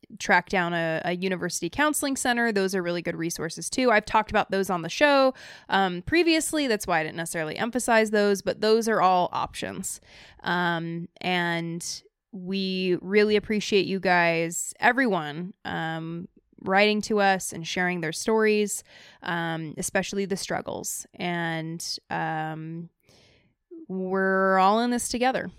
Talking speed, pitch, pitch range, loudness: 145 wpm, 190 Hz, 170-215 Hz, -25 LUFS